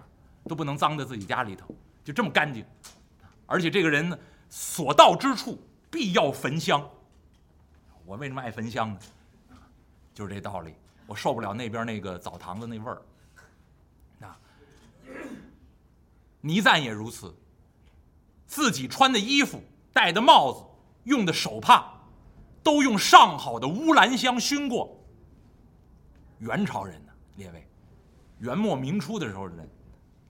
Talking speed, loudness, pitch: 200 characters per minute, -23 LUFS, 110 Hz